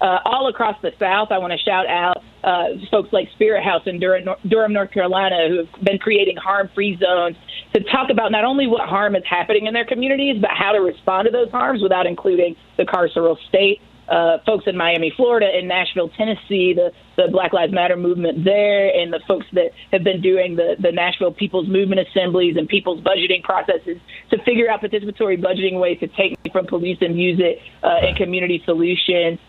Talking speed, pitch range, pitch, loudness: 200 wpm, 175-210 Hz, 190 Hz, -18 LUFS